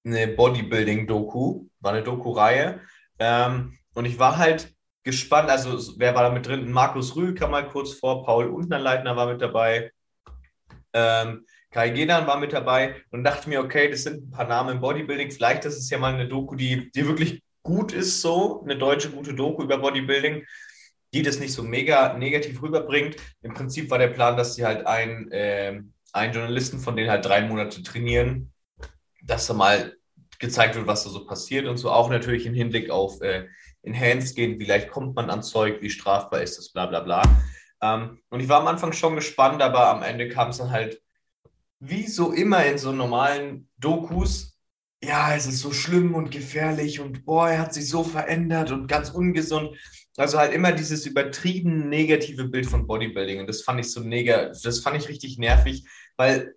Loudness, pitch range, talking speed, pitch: -23 LUFS, 115-145 Hz, 190 wpm, 130 Hz